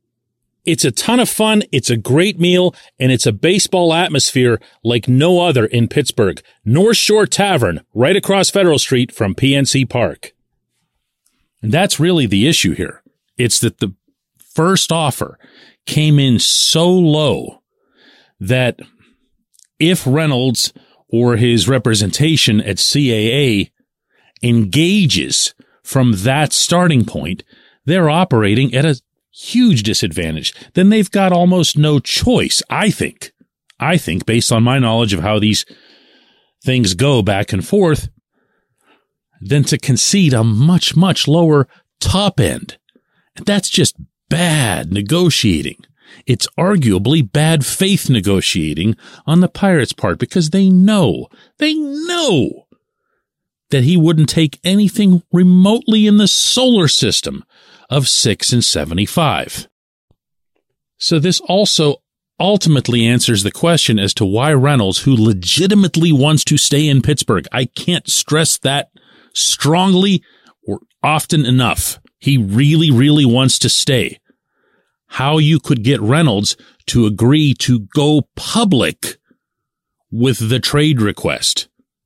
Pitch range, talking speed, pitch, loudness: 120-175 Hz, 125 wpm, 140 Hz, -13 LUFS